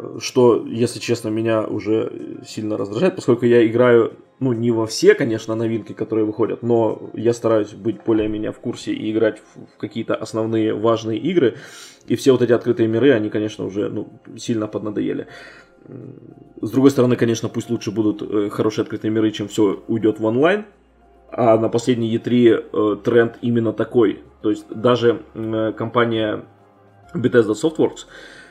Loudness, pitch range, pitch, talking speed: -19 LUFS, 110-120 Hz, 115 Hz, 150 wpm